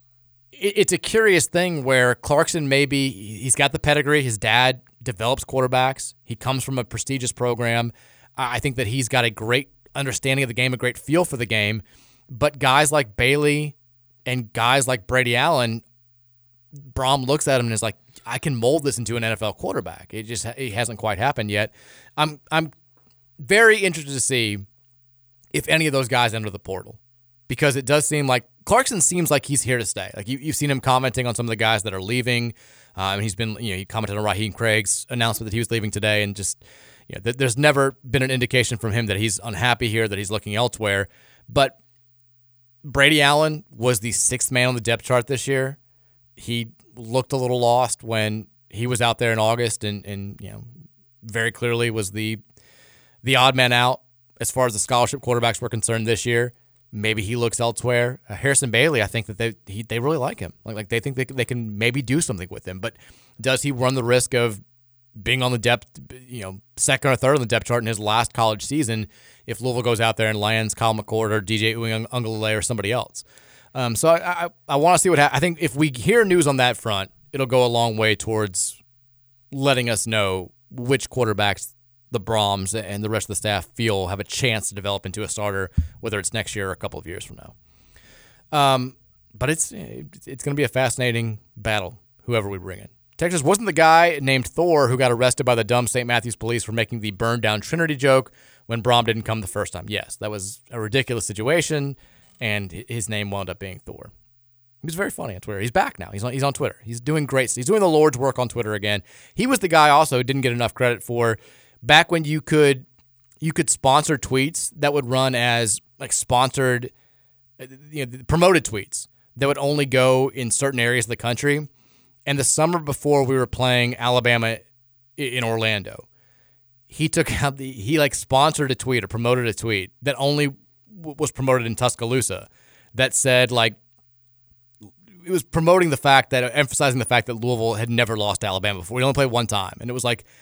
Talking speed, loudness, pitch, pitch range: 210 wpm, -21 LUFS, 120 Hz, 110-135 Hz